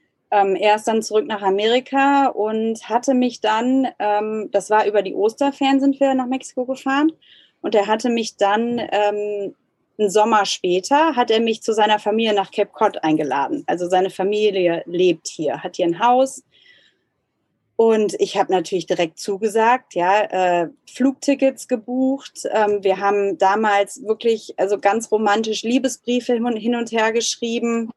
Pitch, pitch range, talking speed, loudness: 215 Hz, 200-245 Hz, 155 wpm, -19 LUFS